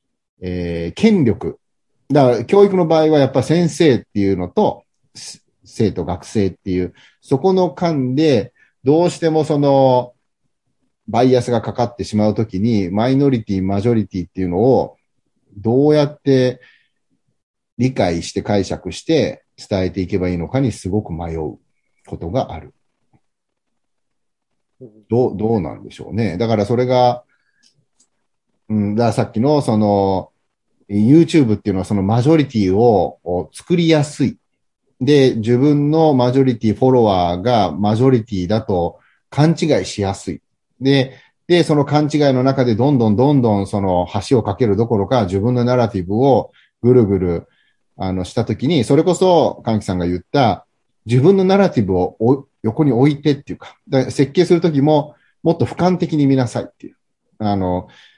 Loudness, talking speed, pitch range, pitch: -16 LUFS, 315 characters per minute, 100-140 Hz, 120 Hz